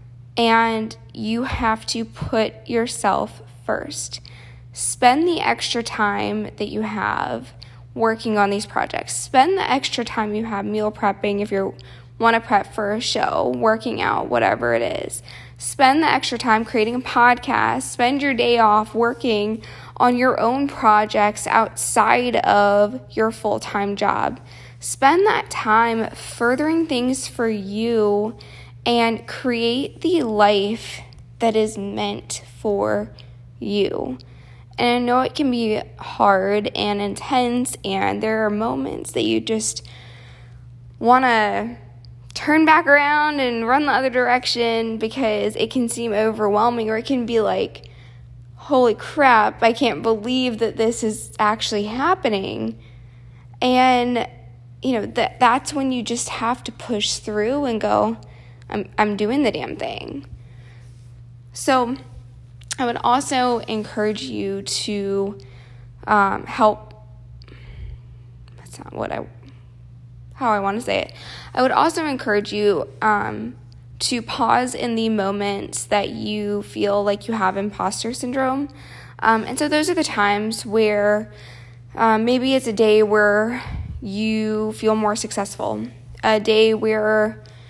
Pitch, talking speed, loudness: 215 Hz, 140 wpm, -20 LUFS